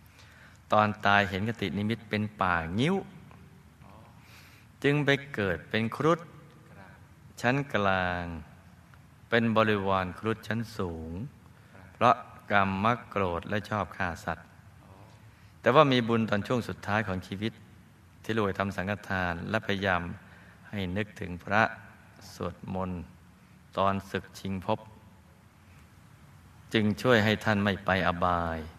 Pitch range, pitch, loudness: 95-110 Hz, 100 Hz, -29 LUFS